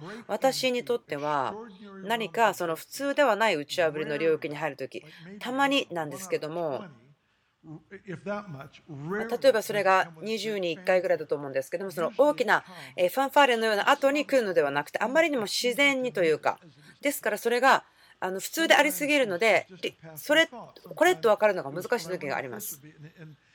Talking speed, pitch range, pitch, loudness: 345 characters per minute, 160-250 Hz, 200 Hz, -26 LUFS